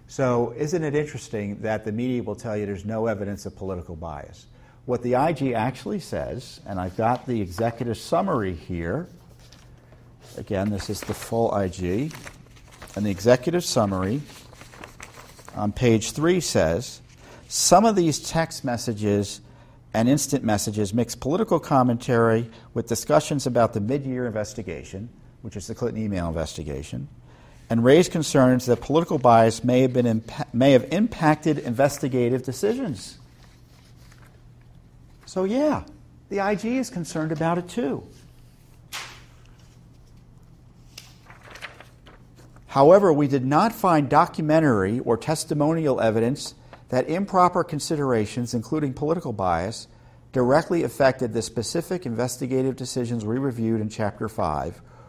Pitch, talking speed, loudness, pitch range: 125 Hz, 125 wpm, -23 LUFS, 110-150 Hz